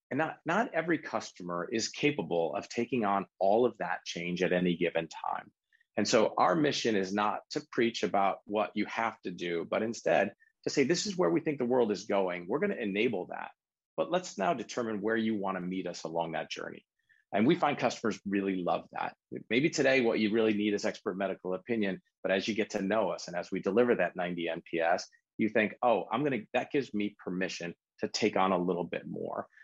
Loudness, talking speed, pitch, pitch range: -31 LUFS, 225 wpm, 100 Hz, 90-115 Hz